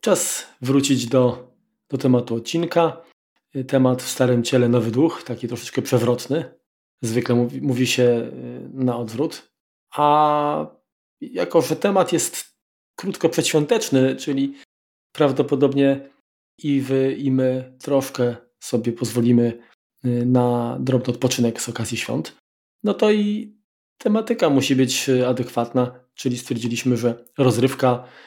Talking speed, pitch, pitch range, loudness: 115 wpm, 130 Hz, 120-140 Hz, -21 LUFS